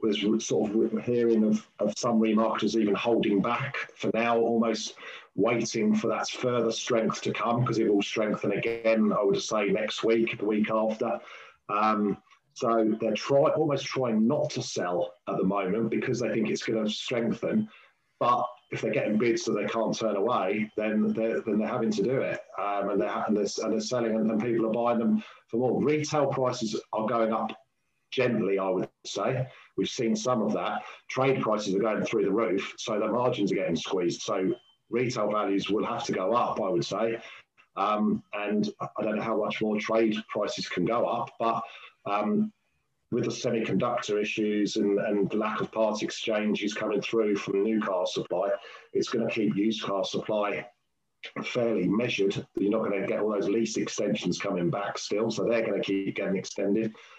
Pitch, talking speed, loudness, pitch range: 110 Hz, 195 wpm, -28 LUFS, 105-115 Hz